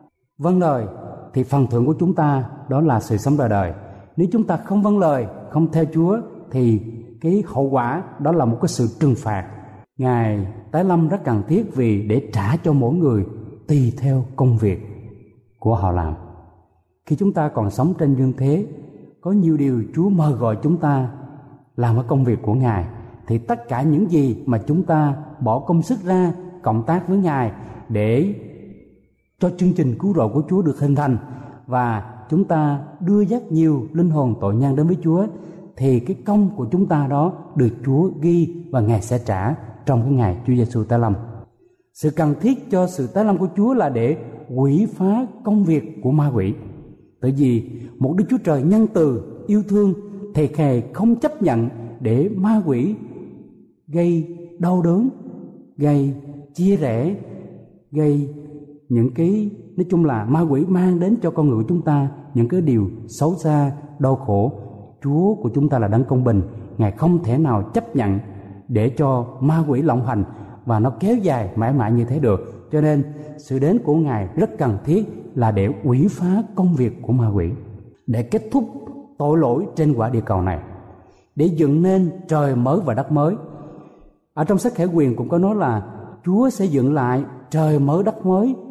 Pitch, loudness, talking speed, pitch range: 145 Hz, -19 LUFS, 190 wpm, 120-170 Hz